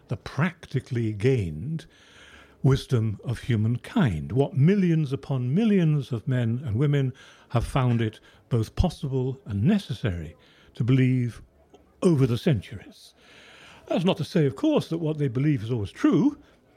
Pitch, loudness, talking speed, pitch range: 135 Hz, -25 LUFS, 140 wpm, 120-155 Hz